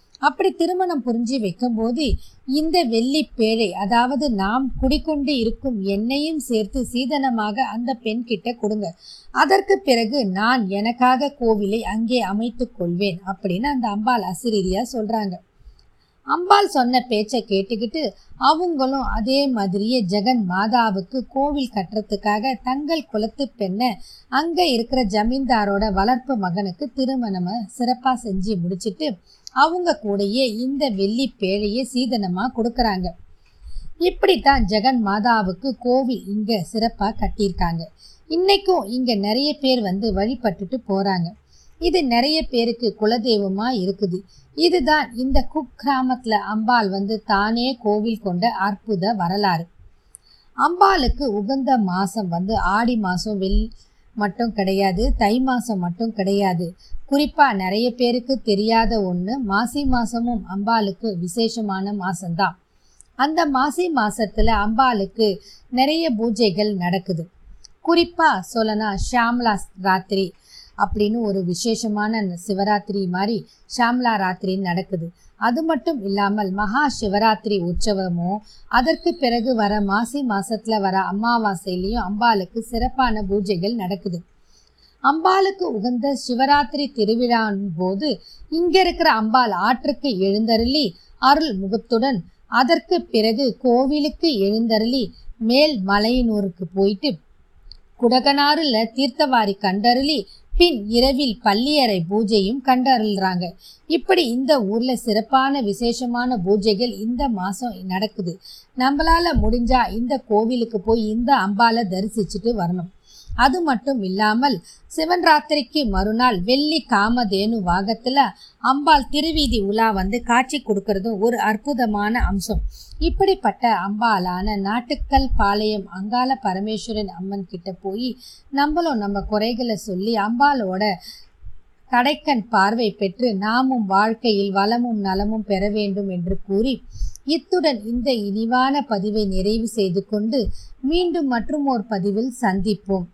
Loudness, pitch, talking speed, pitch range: -20 LUFS, 225 Hz, 100 wpm, 200-260 Hz